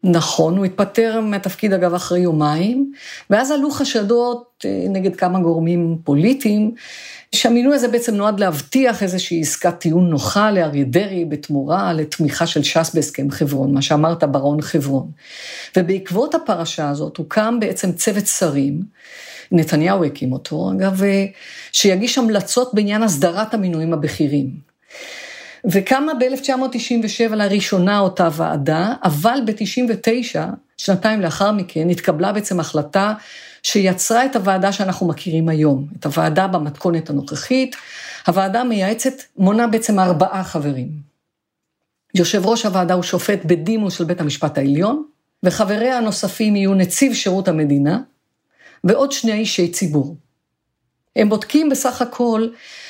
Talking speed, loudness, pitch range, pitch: 120 wpm, -18 LUFS, 165-225 Hz, 190 Hz